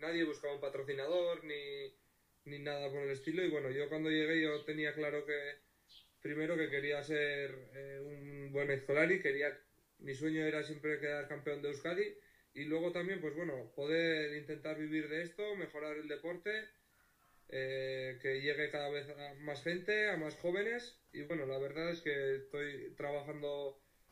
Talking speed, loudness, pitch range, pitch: 170 wpm, -39 LUFS, 145-160 Hz, 150 Hz